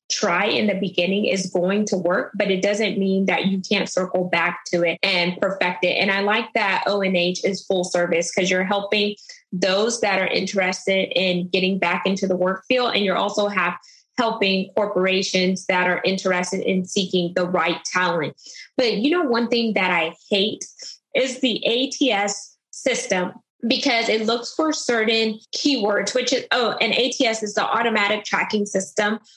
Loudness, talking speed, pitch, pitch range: -21 LUFS, 175 wpm, 195 Hz, 185-220 Hz